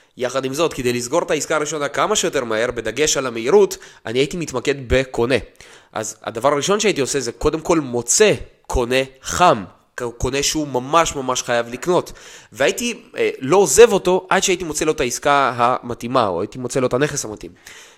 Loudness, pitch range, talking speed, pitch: -18 LUFS, 125-170 Hz, 180 wpm, 140 Hz